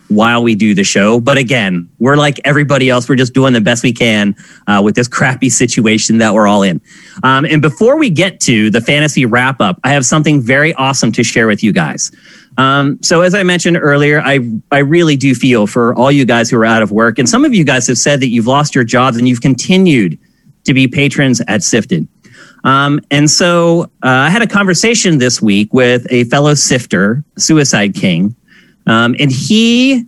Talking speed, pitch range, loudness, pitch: 215 wpm, 120-155 Hz, -10 LUFS, 135 Hz